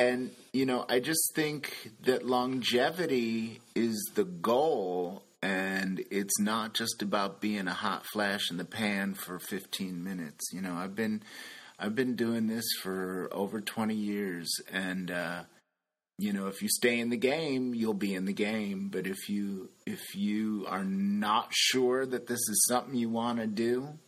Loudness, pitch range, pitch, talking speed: -31 LUFS, 95-125 Hz, 110 Hz, 170 wpm